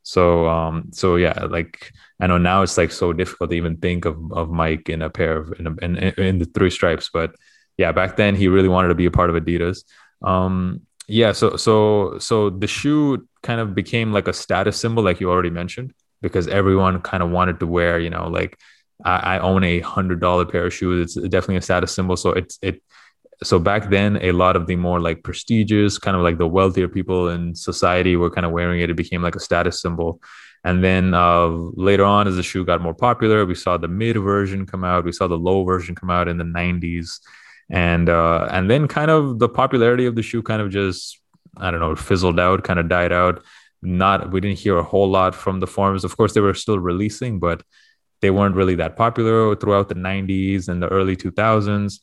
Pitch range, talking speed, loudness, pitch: 85-100 Hz, 225 wpm, -19 LUFS, 95 Hz